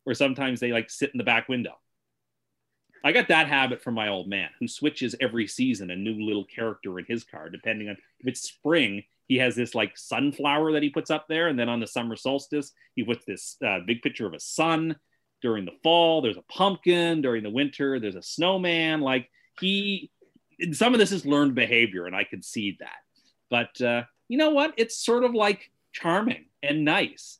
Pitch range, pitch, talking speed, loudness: 115-165 Hz, 135 Hz, 210 wpm, -25 LUFS